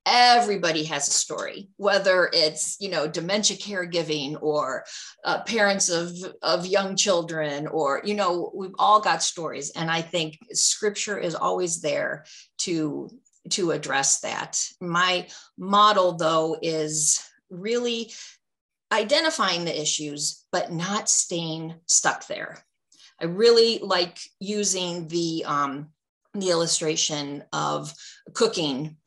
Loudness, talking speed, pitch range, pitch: -23 LUFS, 120 wpm, 155-205 Hz, 175 Hz